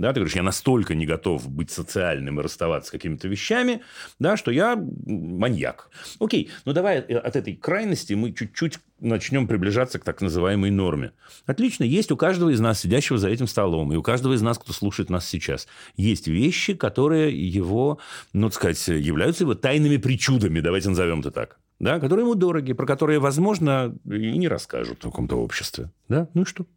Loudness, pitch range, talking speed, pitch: -23 LUFS, 95-145 Hz, 185 wpm, 115 Hz